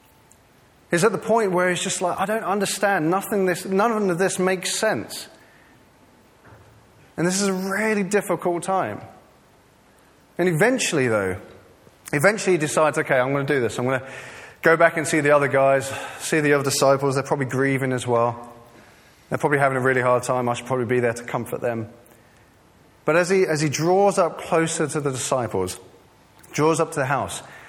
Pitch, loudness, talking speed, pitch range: 150 Hz, -21 LUFS, 190 wpm, 125-185 Hz